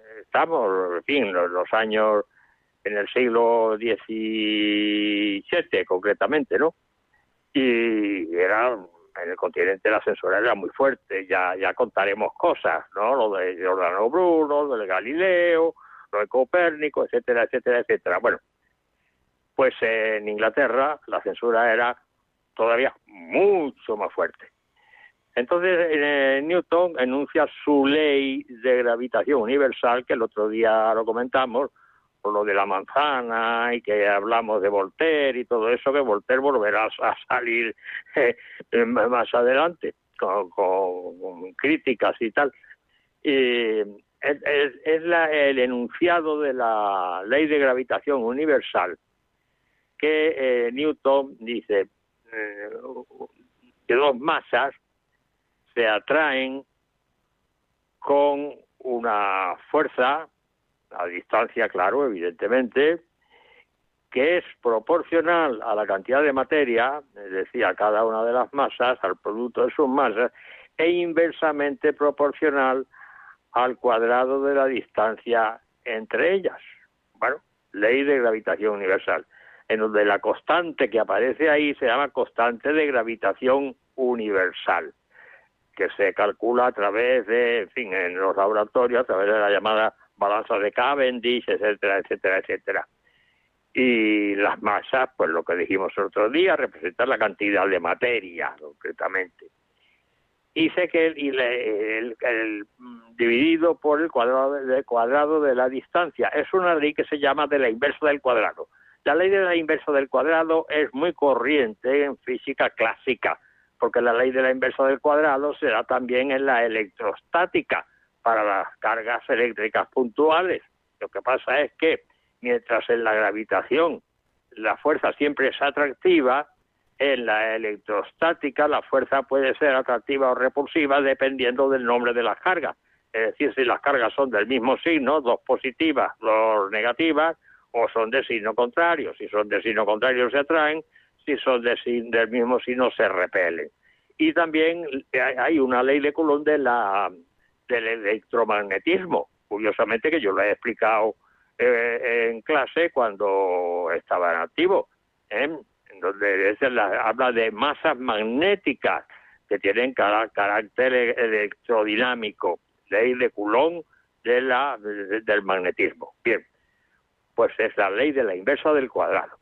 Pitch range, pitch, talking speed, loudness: 115-170 Hz, 135 Hz, 140 wpm, -23 LUFS